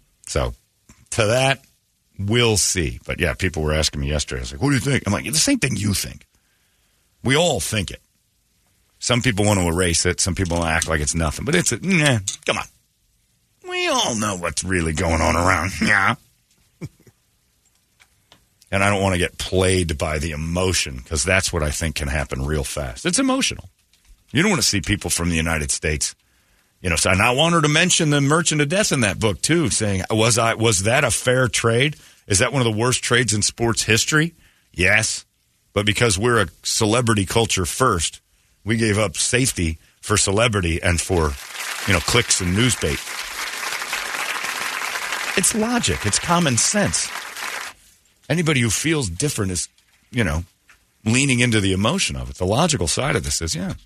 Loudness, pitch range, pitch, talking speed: -19 LUFS, 85-125 Hz, 100 Hz, 190 wpm